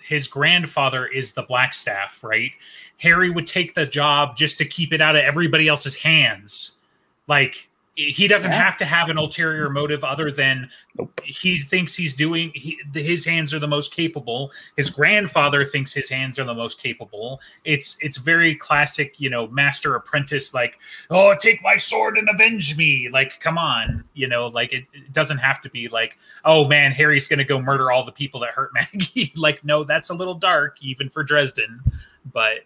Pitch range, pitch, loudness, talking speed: 135-165 Hz, 150 Hz, -19 LUFS, 190 wpm